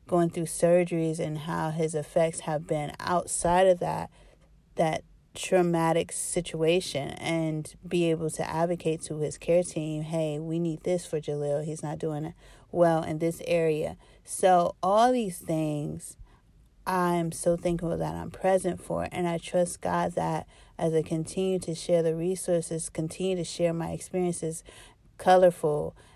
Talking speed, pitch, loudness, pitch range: 150 wpm, 165 Hz, -28 LUFS, 160-175 Hz